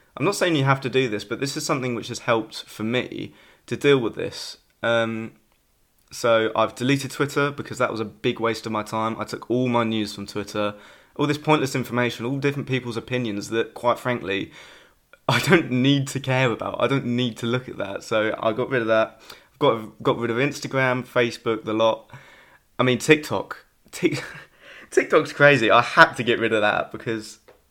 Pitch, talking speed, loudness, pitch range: 120 Hz, 205 wpm, -22 LUFS, 110-135 Hz